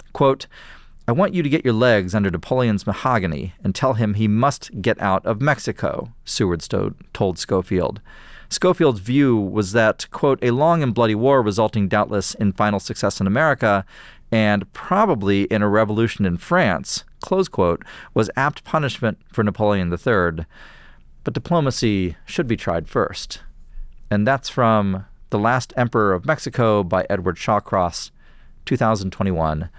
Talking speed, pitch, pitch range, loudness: 150 wpm, 110 Hz, 95-125 Hz, -20 LUFS